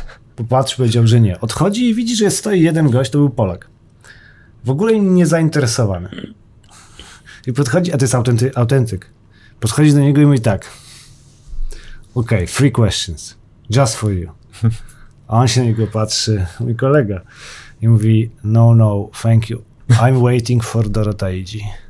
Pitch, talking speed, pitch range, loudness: 120 Hz, 150 wpm, 110-135 Hz, -15 LUFS